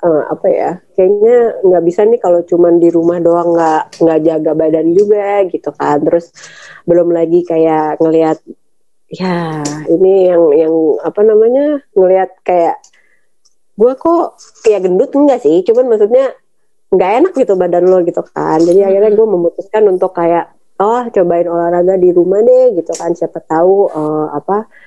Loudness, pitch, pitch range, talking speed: -11 LUFS, 180 Hz, 165-215 Hz, 160 wpm